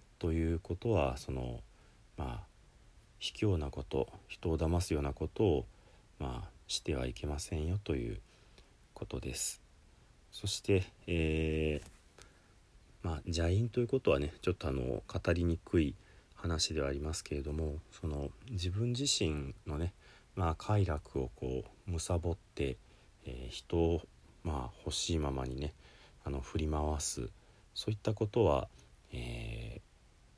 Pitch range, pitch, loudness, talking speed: 70-95 Hz, 80 Hz, -36 LUFS, 230 characters per minute